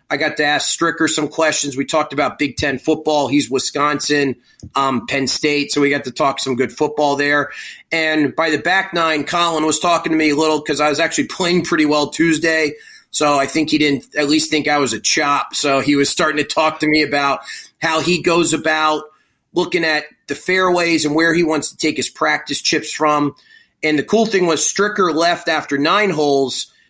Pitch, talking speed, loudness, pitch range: 155 Hz, 215 wpm, -16 LUFS, 145-165 Hz